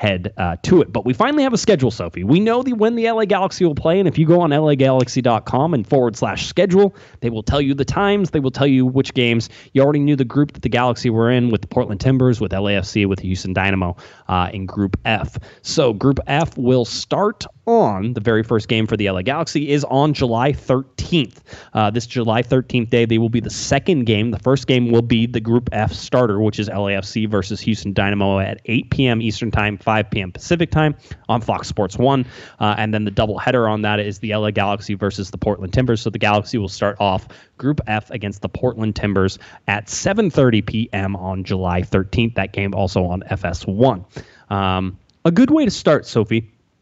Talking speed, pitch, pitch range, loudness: 215 wpm, 115 Hz, 100-135 Hz, -18 LUFS